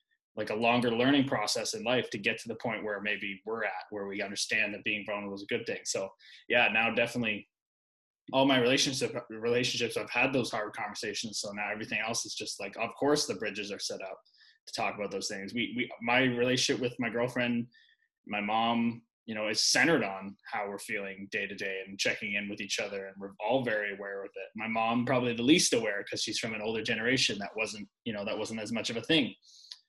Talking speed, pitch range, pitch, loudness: 230 wpm, 100-125 Hz, 115 Hz, -31 LUFS